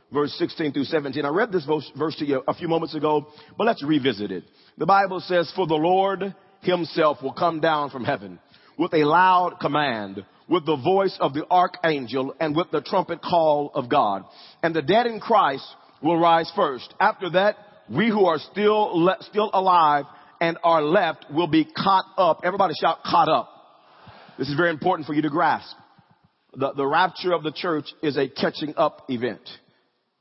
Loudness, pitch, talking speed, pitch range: -22 LUFS, 165 Hz, 185 wpm, 150-185 Hz